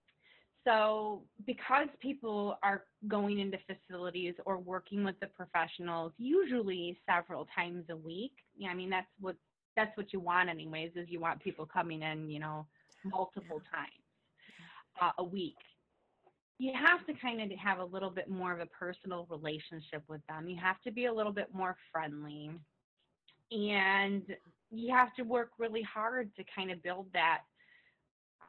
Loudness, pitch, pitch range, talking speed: -36 LUFS, 190 Hz, 175-215 Hz, 160 wpm